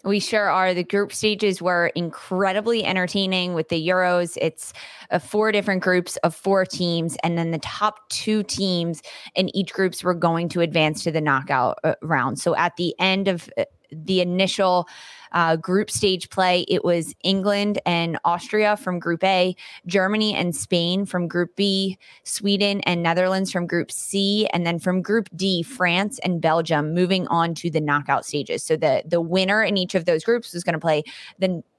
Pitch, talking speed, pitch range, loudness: 185 Hz, 180 wpm, 170-195 Hz, -22 LUFS